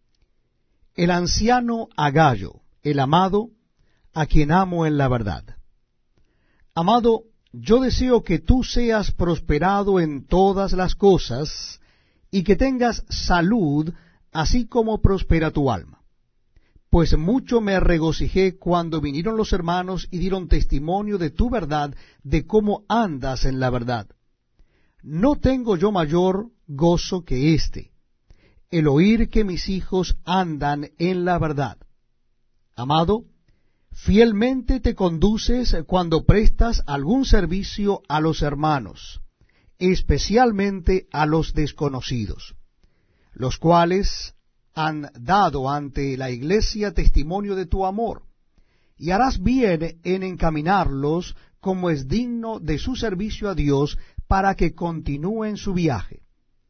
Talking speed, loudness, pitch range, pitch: 115 wpm, -21 LUFS, 145-205 Hz, 175 Hz